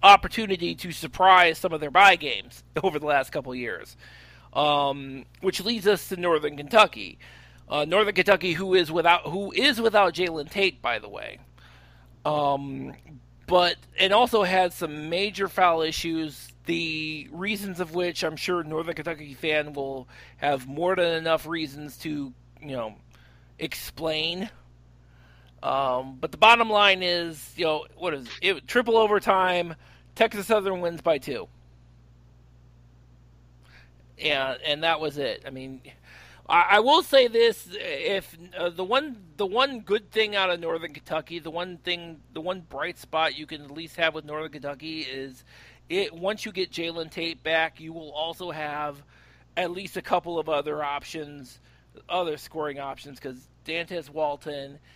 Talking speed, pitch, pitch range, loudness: 160 wpm, 160 Hz, 140-185 Hz, -25 LUFS